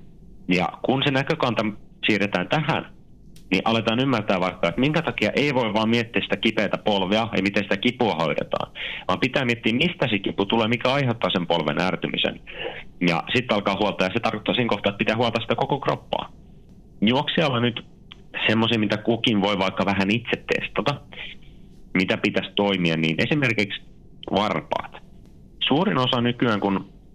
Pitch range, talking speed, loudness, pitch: 100-120 Hz, 160 wpm, -23 LUFS, 110 Hz